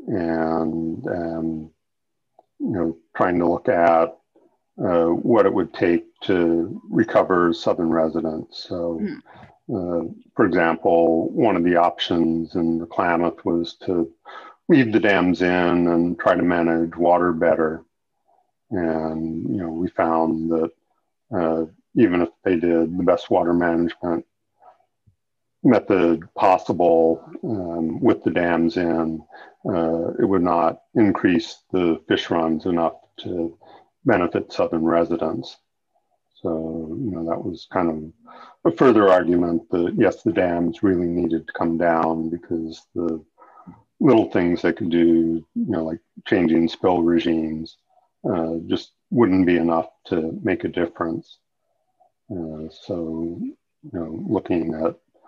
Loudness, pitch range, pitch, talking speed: -21 LUFS, 80-85 Hz, 85 Hz, 130 wpm